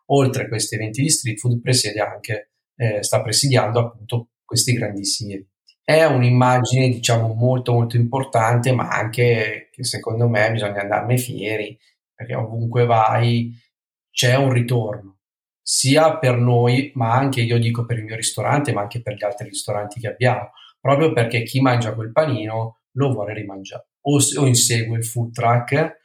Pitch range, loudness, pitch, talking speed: 110-130 Hz, -19 LUFS, 120 Hz, 160 wpm